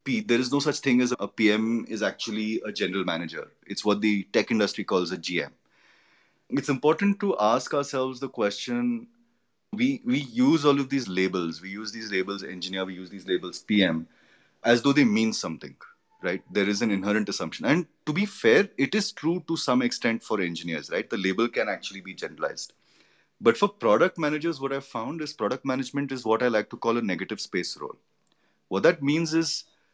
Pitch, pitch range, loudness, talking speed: 130 Hz, 105-160 Hz, -26 LUFS, 200 wpm